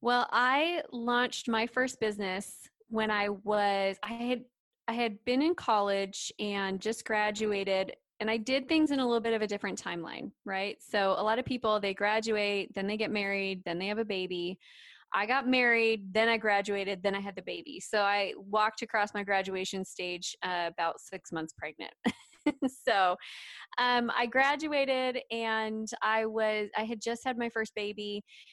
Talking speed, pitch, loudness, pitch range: 180 wpm, 215 Hz, -31 LUFS, 200-235 Hz